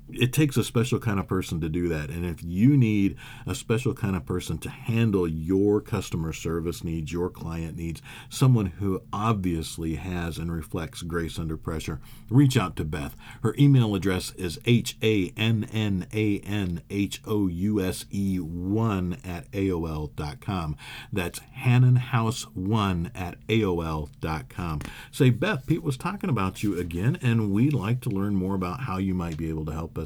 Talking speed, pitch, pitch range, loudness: 175 wpm, 100 Hz, 85-115 Hz, -26 LUFS